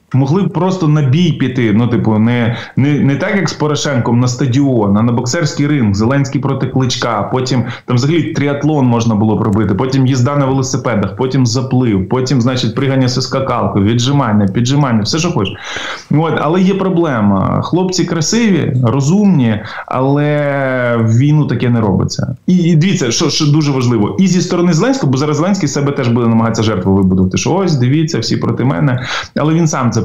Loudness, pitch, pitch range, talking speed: -13 LUFS, 135 Hz, 120-150 Hz, 175 wpm